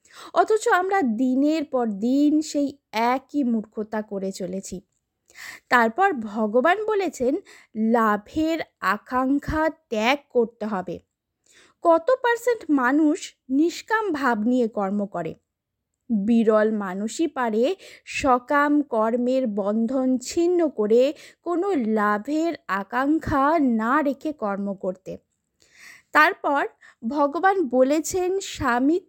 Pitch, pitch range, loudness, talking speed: 260 Hz, 220-320 Hz, -23 LUFS, 95 wpm